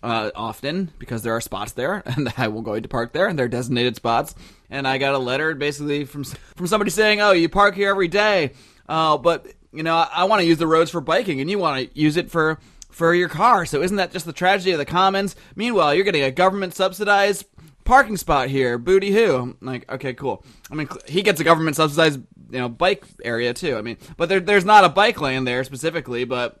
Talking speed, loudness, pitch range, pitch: 235 wpm, -20 LUFS, 130-190 Hz, 160 Hz